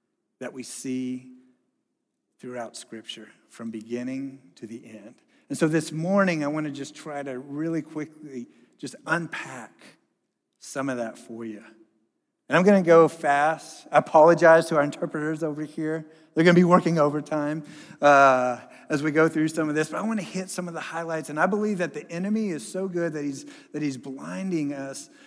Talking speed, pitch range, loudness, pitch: 180 wpm, 130-165 Hz, -24 LUFS, 150 Hz